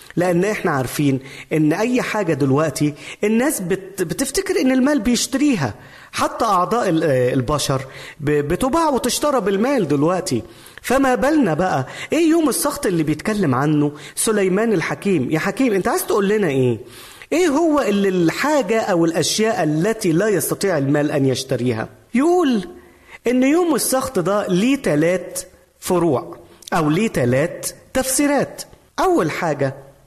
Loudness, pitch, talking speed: -18 LUFS, 190 Hz, 125 wpm